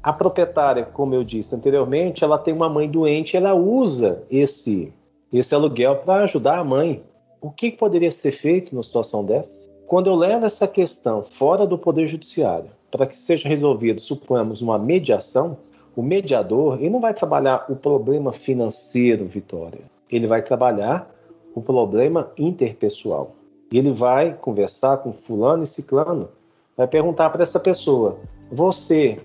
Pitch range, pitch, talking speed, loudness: 125-175 Hz, 145 Hz, 150 wpm, -20 LUFS